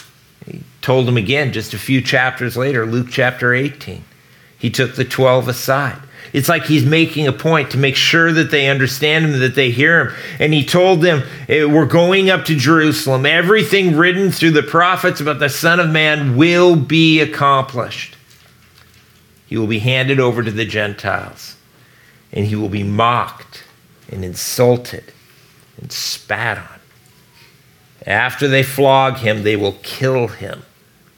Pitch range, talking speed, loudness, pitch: 125-155 Hz, 155 wpm, -14 LUFS, 135 Hz